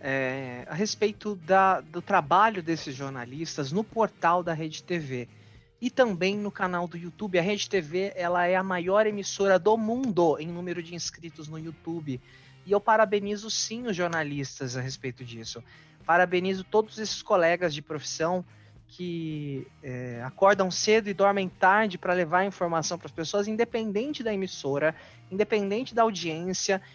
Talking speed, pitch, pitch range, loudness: 155 wpm, 175 Hz, 155-205 Hz, -27 LUFS